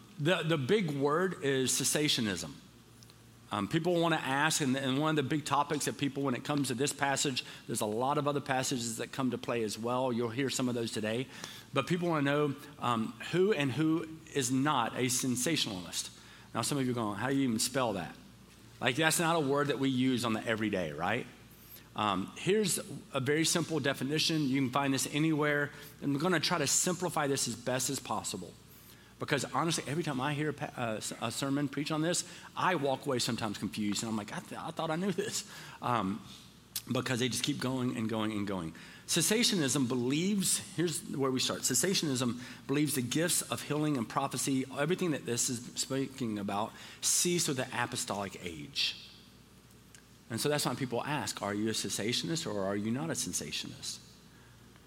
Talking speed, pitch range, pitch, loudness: 200 wpm, 120-155 Hz, 135 Hz, -32 LUFS